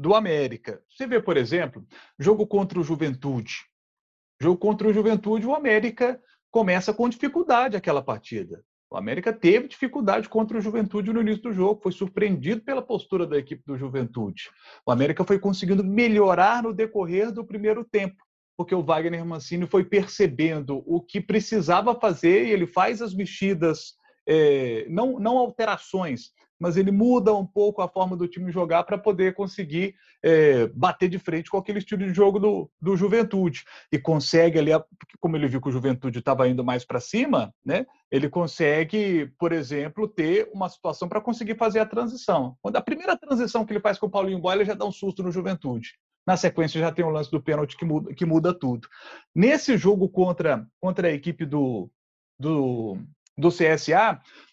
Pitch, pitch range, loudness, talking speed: 190 Hz, 160-215 Hz, -24 LUFS, 180 wpm